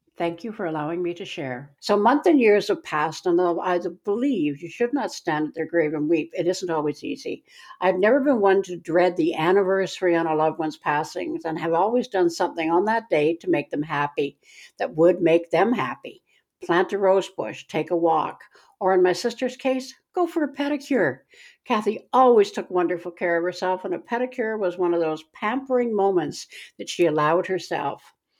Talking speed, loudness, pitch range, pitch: 200 wpm, -23 LUFS, 165-235 Hz, 180 Hz